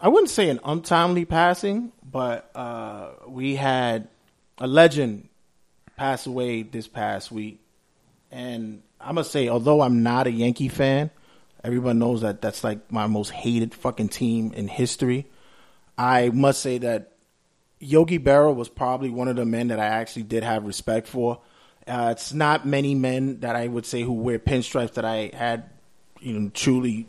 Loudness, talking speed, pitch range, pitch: -23 LUFS, 170 wpm, 115-135 Hz, 125 Hz